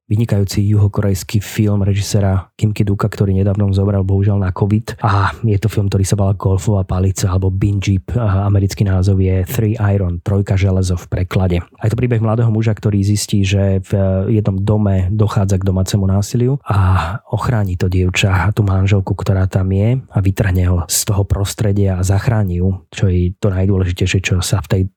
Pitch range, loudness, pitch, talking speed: 95-105 Hz, -16 LUFS, 100 Hz, 180 wpm